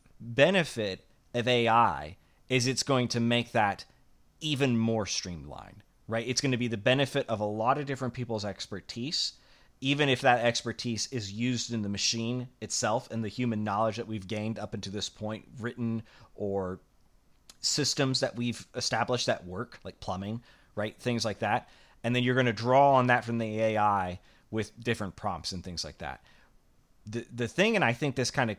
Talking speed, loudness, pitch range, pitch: 185 wpm, -29 LUFS, 105-125 Hz, 115 Hz